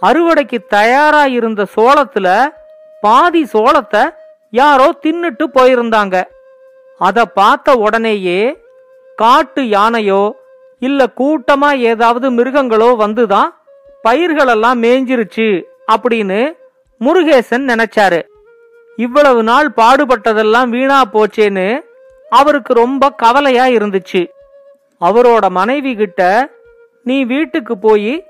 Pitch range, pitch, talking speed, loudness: 225-300 Hz, 260 Hz, 85 wpm, -11 LUFS